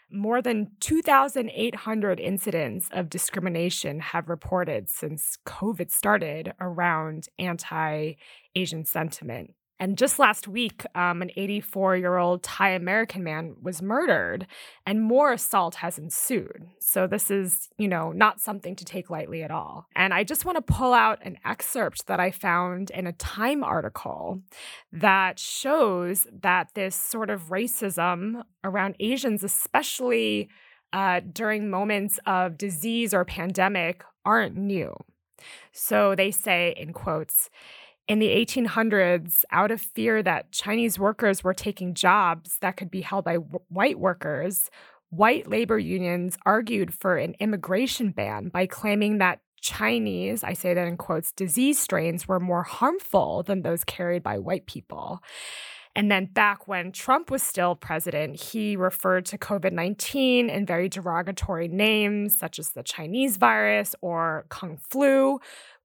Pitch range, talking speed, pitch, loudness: 180-215 Hz, 140 wpm, 190 Hz, -25 LUFS